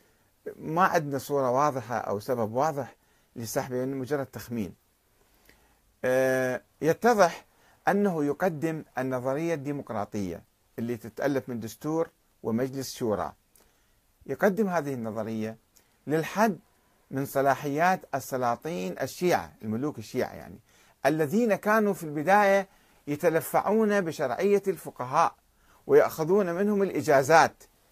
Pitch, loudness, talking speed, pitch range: 145 Hz, -27 LUFS, 90 wpm, 125-180 Hz